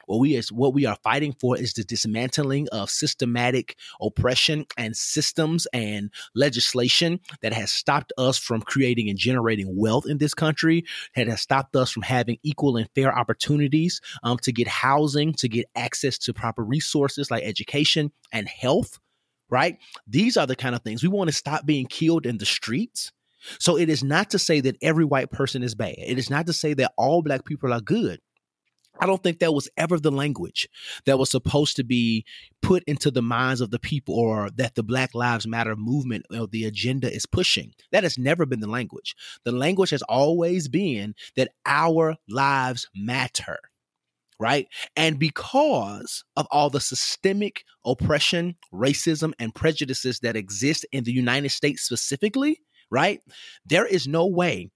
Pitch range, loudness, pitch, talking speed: 120-155 Hz, -23 LUFS, 135 Hz, 180 wpm